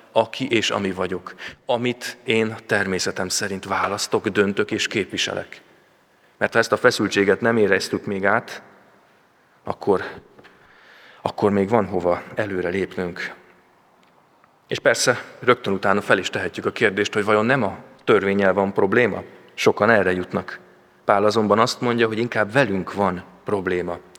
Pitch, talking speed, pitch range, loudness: 105 Hz, 140 wpm, 95-115 Hz, -21 LUFS